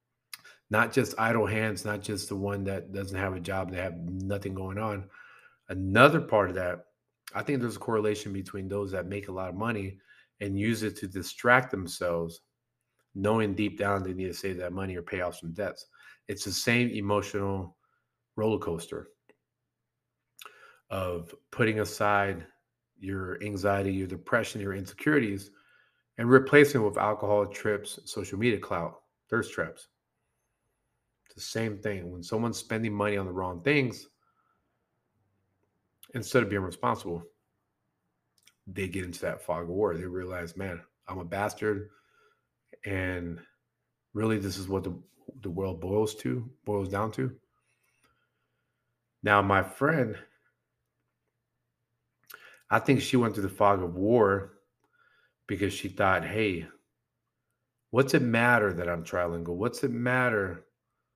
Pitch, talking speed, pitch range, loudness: 100 Hz, 145 wpm, 95-110 Hz, -29 LUFS